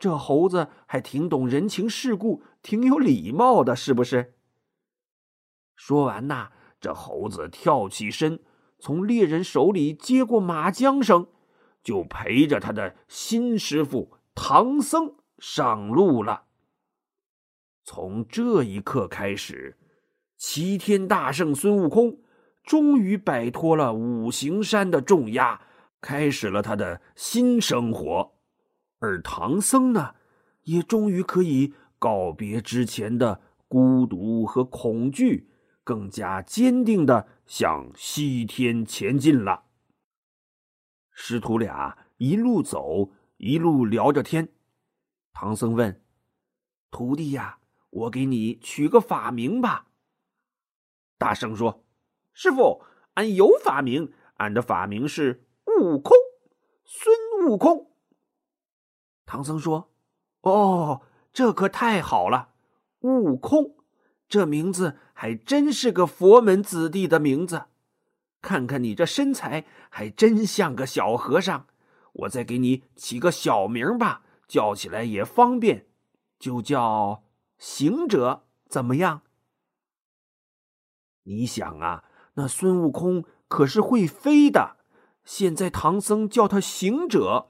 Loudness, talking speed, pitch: -23 LUFS, 160 characters per minute, 165 Hz